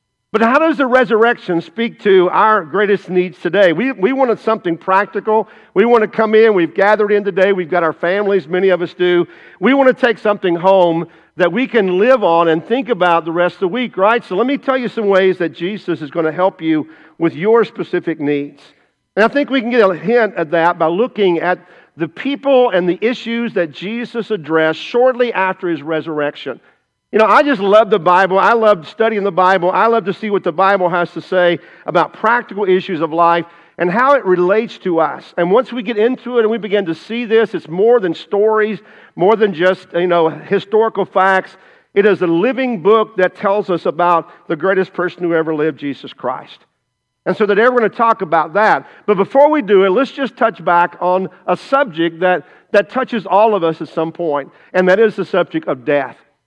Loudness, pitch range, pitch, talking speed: -14 LUFS, 170-225 Hz, 190 Hz, 220 wpm